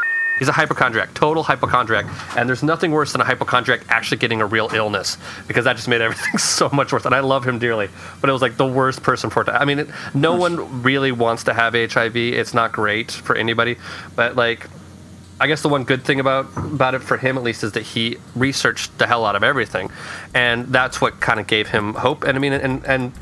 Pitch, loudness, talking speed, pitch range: 130 Hz, -18 LUFS, 235 wpm, 115-135 Hz